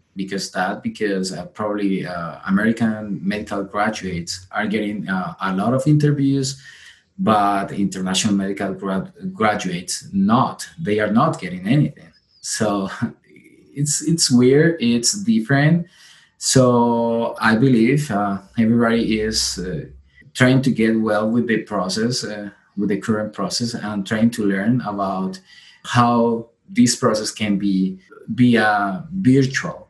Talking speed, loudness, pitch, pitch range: 130 wpm, -19 LUFS, 110 Hz, 100-125 Hz